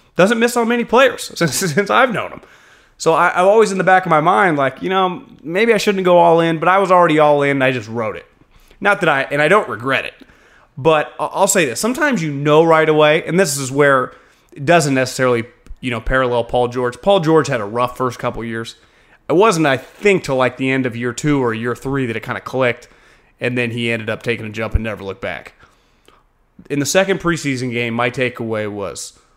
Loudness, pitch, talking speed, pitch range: -16 LUFS, 145 Hz, 235 wpm, 120-180 Hz